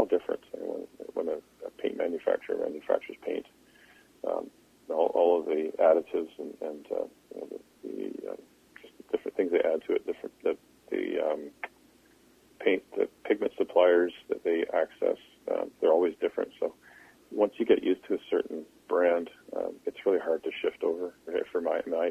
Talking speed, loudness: 185 wpm, -30 LUFS